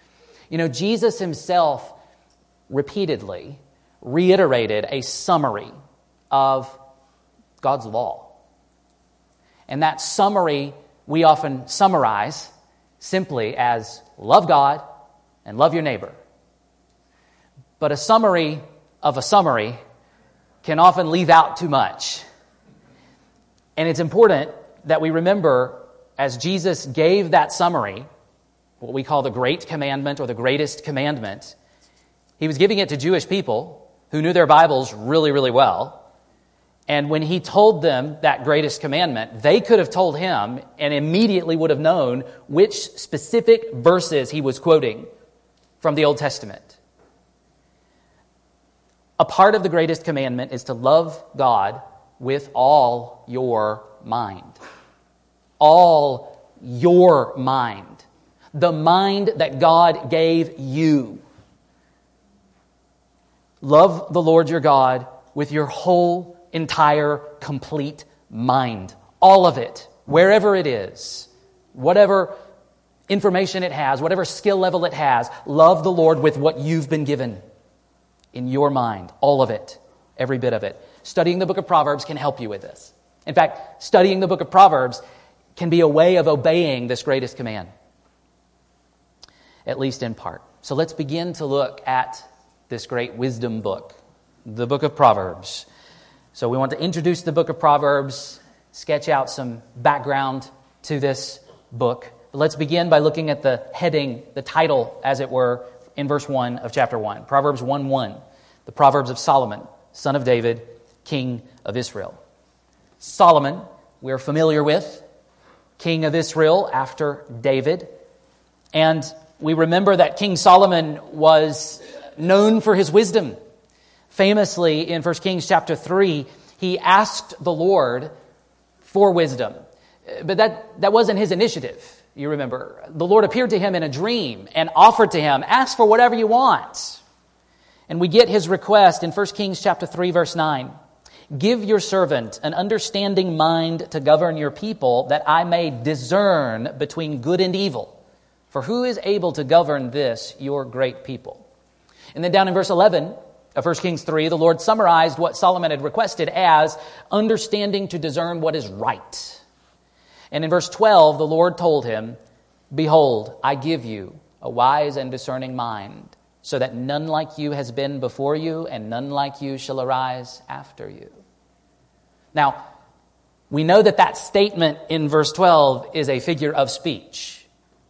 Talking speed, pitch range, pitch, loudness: 145 wpm, 135-175 Hz, 155 Hz, -19 LUFS